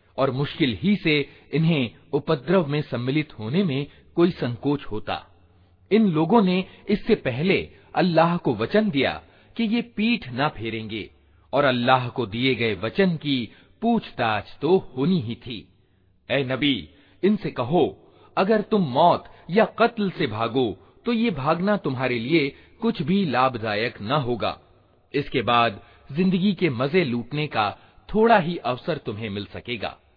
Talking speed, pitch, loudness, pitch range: 145 wpm, 145 Hz, -23 LUFS, 120-190 Hz